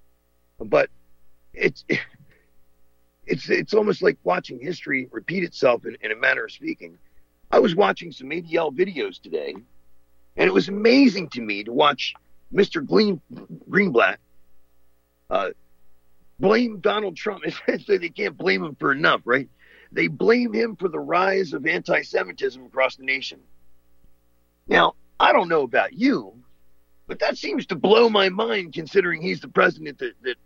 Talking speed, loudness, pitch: 150 wpm, -22 LUFS, 125 Hz